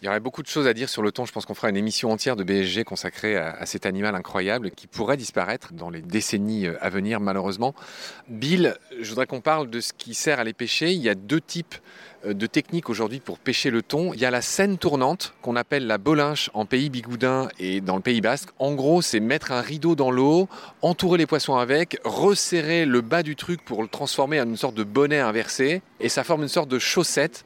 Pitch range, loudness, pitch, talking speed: 110-155 Hz, -24 LUFS, 130 Hz, 240 wpm